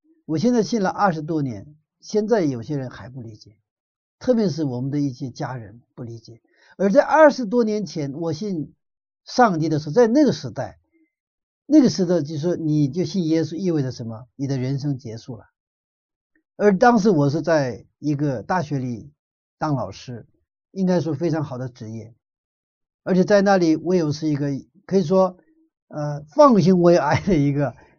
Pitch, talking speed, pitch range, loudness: 160 Hz, 255 characters per minute, 135-195 Hz, -20 LUFS